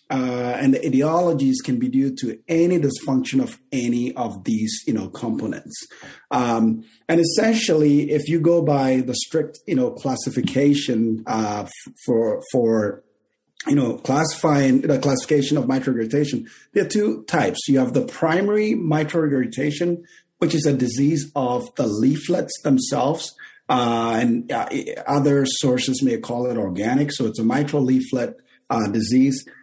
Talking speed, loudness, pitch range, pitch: 150 wpm, -21 LUFS, 125-160 Hz, 135 Hz